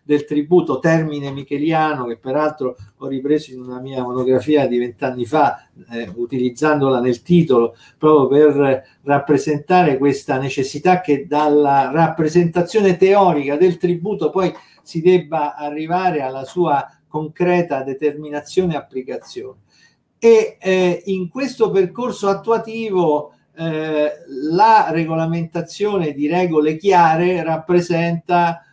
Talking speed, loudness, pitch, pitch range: 110 wpm, -17 LUFS, 155 Hz, 140-180 Hz